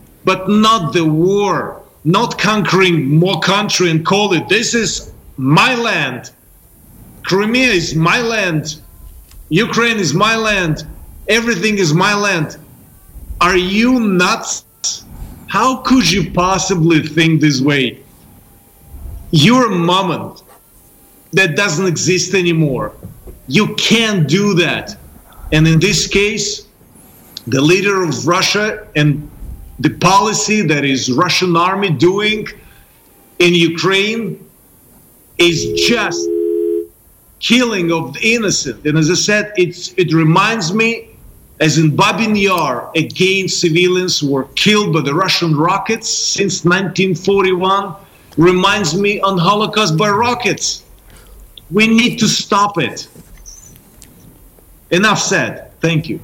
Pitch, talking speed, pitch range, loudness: 180 Hz, 115 wpm, 155-205 Hz, -13 LUFS